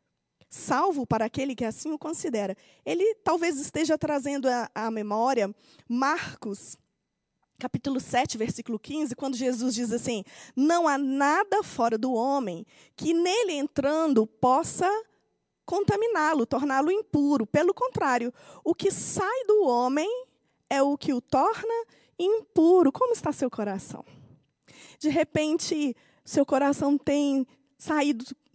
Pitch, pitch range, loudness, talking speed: 280 Hz, 245-330 Hz, -26 LUFS, 120 wpm